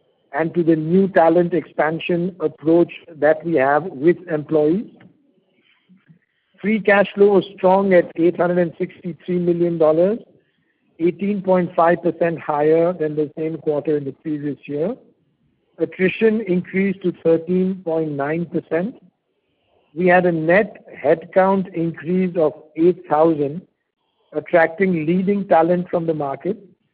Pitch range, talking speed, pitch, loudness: 160-185 Hz, 105 wpm, 170 Hz, -19 LUFS